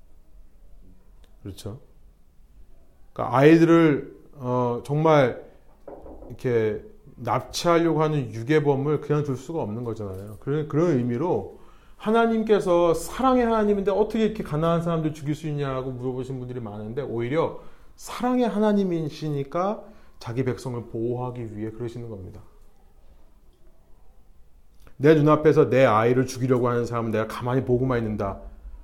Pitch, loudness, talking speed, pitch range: 130 Hz, -23 LUFS, 310 characters per minute, 105-155 Hz